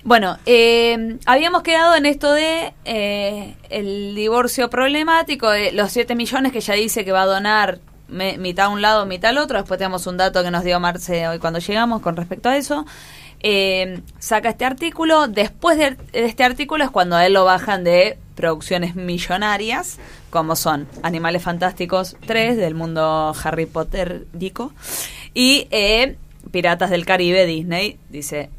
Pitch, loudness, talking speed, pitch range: 200 Hz, -18 LUFS, 165 wpm, 180-240 Hz